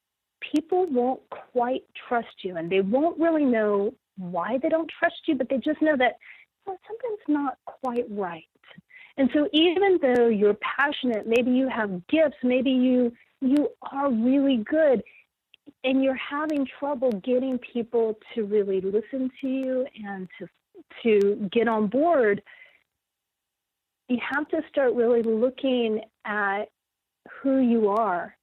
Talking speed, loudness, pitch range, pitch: 145 wpm, -25 LUFS, 225-290 Hz, 255 Hz